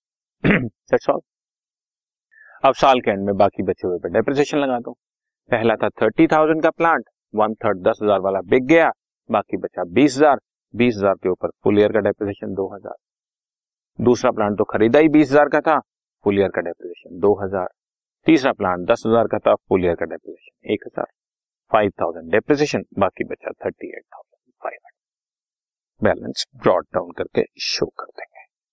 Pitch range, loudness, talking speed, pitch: 100-145 Hz, -19 LUFS, 140 wpm, 110 Hz